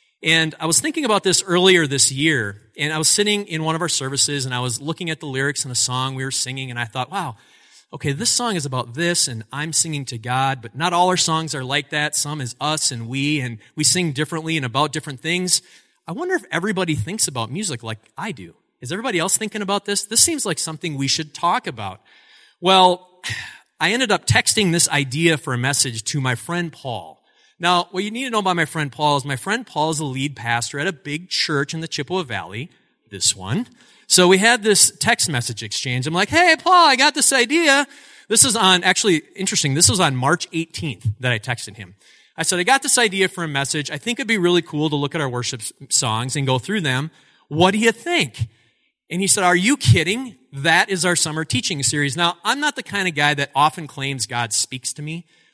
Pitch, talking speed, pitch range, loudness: 155 Hz, 235 wpm, 135-185 Hz, -18 LUFS